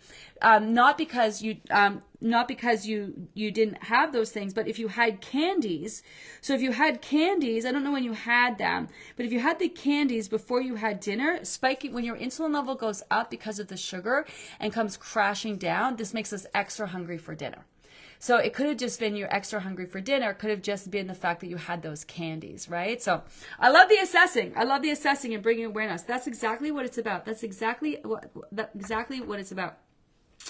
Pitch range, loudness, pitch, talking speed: 205-260 Hz, -27 LUFS, 225 Hz, 215 wpm